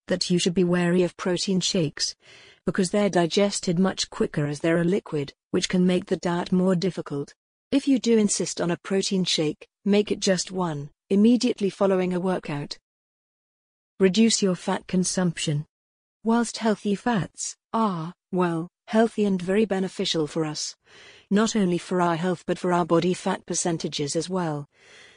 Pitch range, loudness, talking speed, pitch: 175-205 Hz, -24 LUFS, 160 wpm, 185 Hz